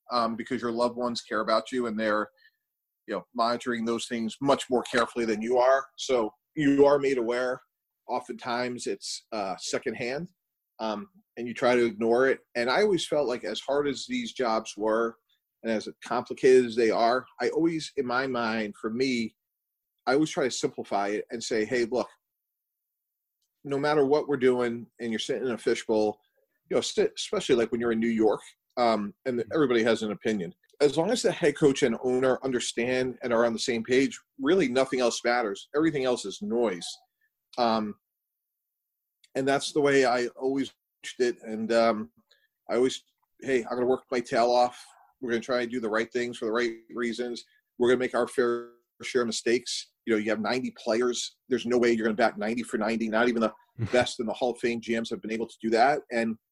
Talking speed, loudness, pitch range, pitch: 210 wpm, -27 LUFS, 115-135 Hz, 120 Hz